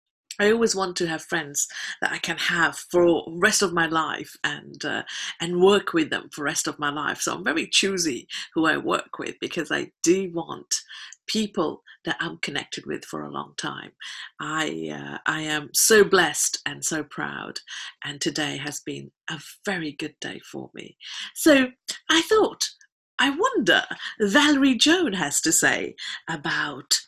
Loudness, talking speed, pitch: -23 LUFS, 175 wpm, 190 Hz